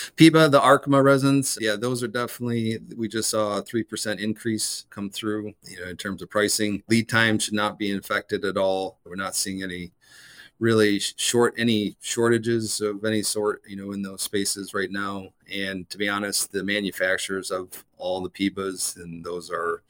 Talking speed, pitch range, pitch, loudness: 185 wpm, 95-115 Hz, 105 Hz, -24 LUFS